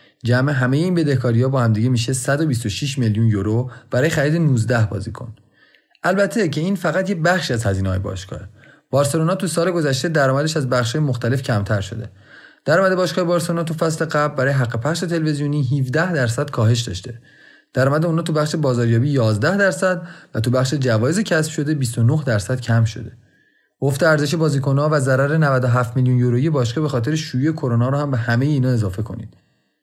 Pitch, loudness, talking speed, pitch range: 135 Hz, -19 LUFS, 175 wpm, 120-155 Hz